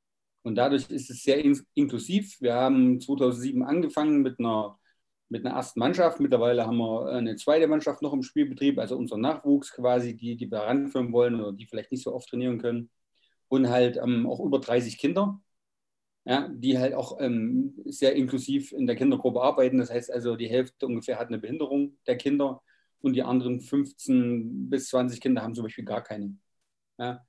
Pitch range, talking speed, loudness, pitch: 120-140 Hz, 185 wpm, -27 LUFS, 130 Hz